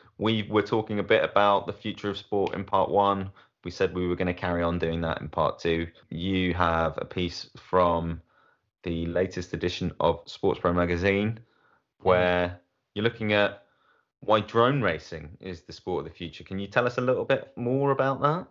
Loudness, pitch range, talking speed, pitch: -27 LUFS, 85-110 Hz, 200 wpm, 95 Hz